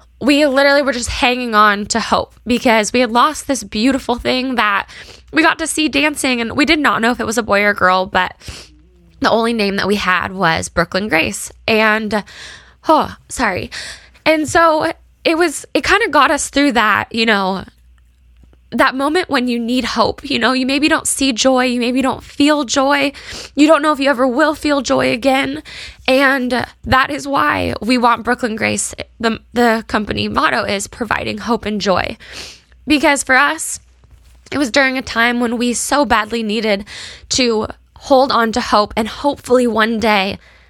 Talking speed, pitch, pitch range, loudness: 185 wpm, 245 Hz, 210-280 Hz, -15 LUFS